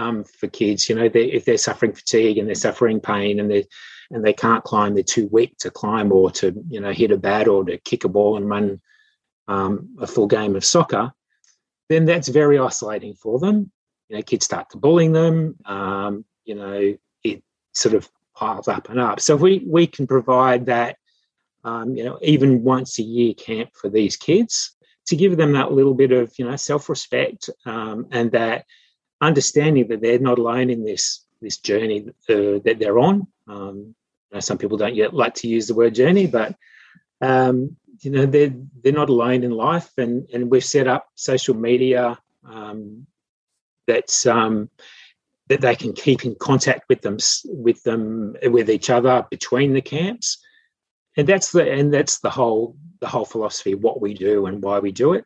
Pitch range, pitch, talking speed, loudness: 110-140 Hz, 120 Hz, 195 wpm, -19 LUFS